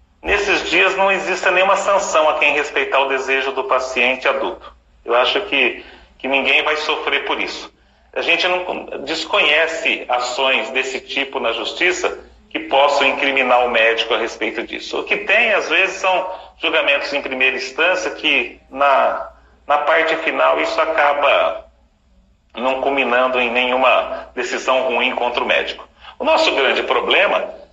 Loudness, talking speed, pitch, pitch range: -16 LUFS, 150 wpm, 140 Hz, 130-185 Hz